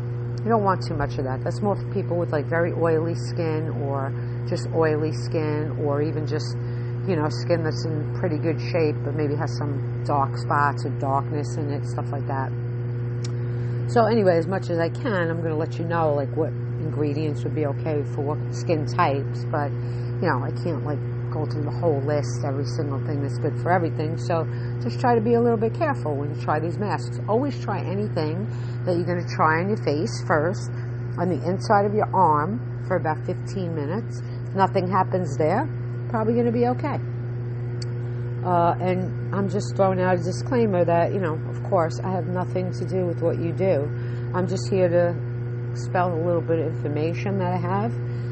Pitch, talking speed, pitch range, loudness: 120 Hz, 200 wpm, 120-135 Hz, -24 LUFS